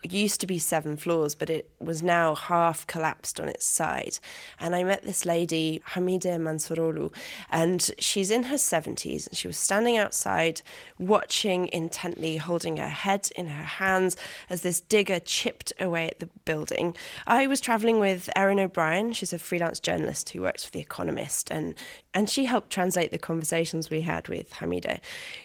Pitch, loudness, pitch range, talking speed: 180 Hz, -27 LUFS, 165-200 Hz, 170 wpm